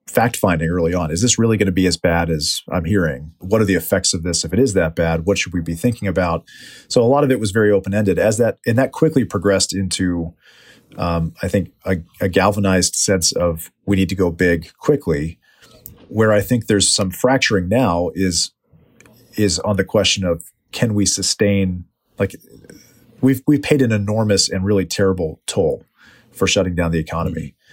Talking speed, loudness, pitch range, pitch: 200 wpm, -17 LUFS, 85-105 Hz, 95 Hz